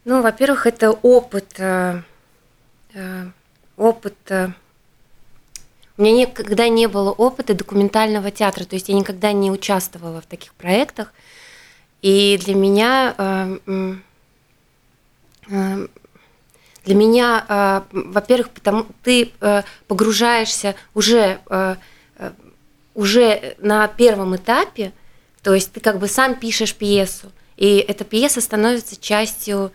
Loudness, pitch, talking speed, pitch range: -17 LUFS, 200 Hz, 115 wpm, 190-225 Hz